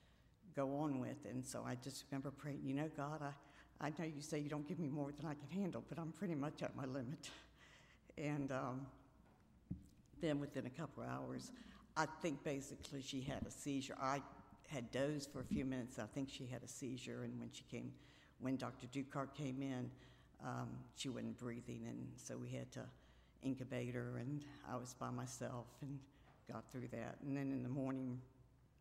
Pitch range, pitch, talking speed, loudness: 125-145 Hz, 135 Hz, 200 wpm, -47 LUFS